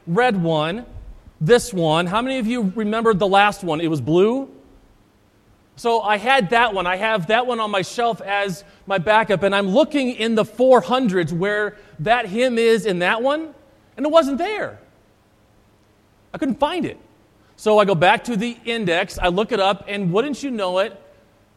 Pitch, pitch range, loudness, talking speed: 210 Hz, 170-235 Hz, -19 LUFS, 185 wpm